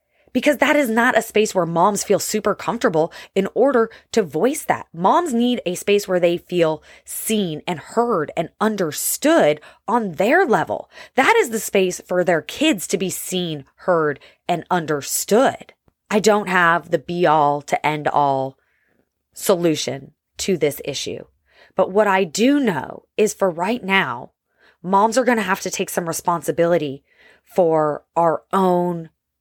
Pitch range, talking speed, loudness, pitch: 165-220 Hz, 160 wpm, -19 LUFS, 185 Hz